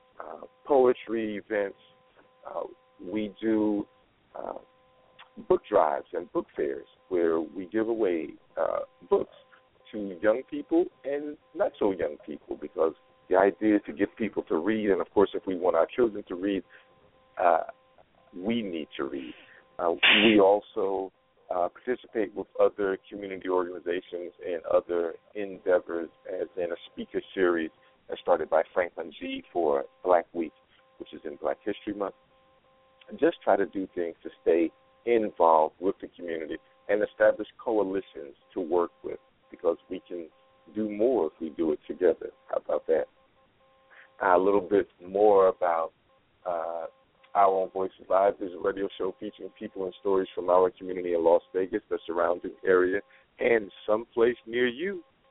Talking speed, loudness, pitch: 155 wpm, -28 LUFS, 115 Hz